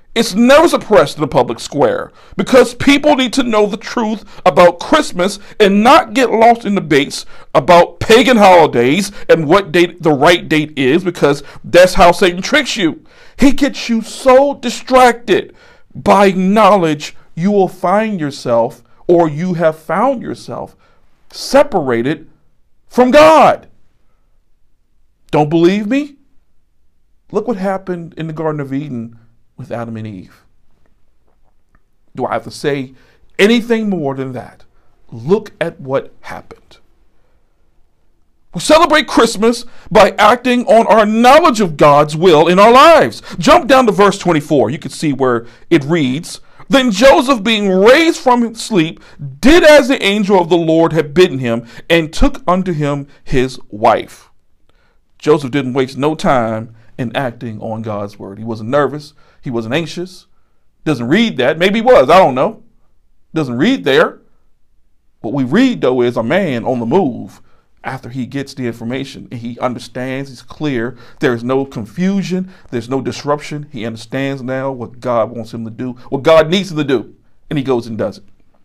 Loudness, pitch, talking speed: -12 LUFS, 175 Hz, 160 wpm